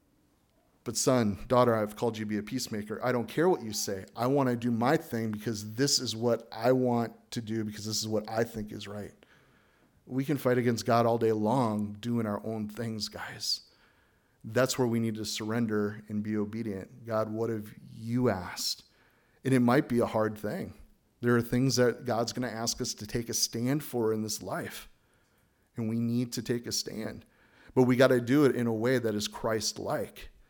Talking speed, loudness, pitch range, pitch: 215 wpm, -30 LUFS, 110-125 Hz, 115 Hz